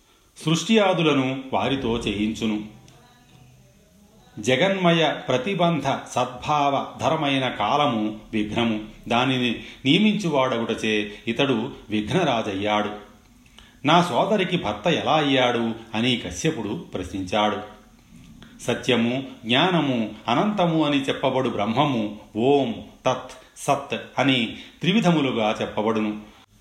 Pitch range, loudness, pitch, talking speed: 110-145 Hz, -23 LUFS, 125 Hz, 75 wpm